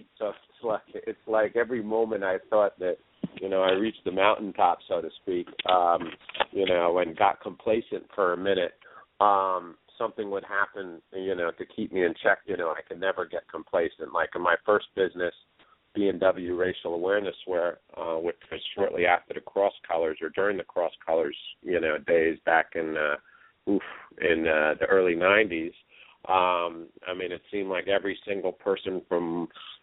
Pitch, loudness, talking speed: 100 Hz, -27 LUFS, 185 wpm